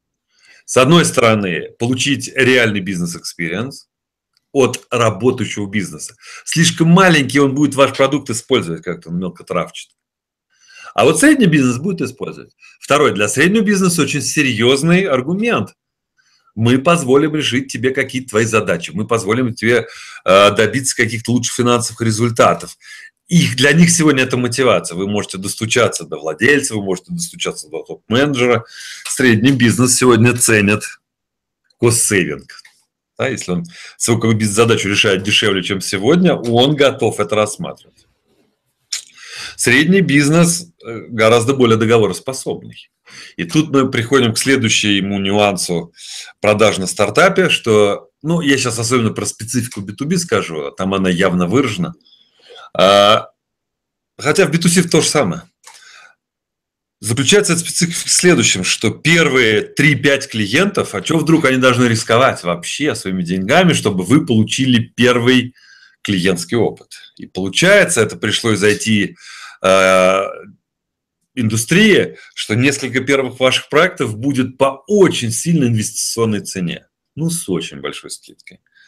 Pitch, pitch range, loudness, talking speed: 125 Hz, 110-150 Hz, -14 LUFS, 125 wpm